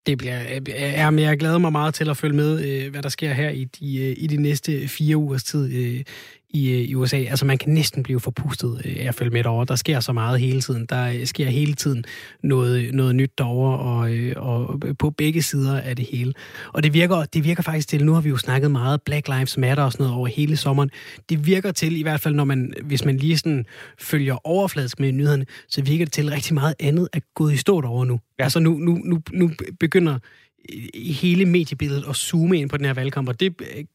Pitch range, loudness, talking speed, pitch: 130-155 Hz, -21 LUFS, 230 wpm, 140 Hz